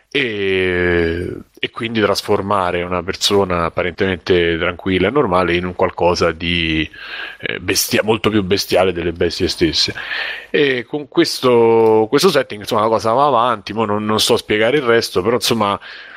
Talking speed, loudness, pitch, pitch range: 150 wpm, -16 LUFS, 100 Hz, 90-115 Hz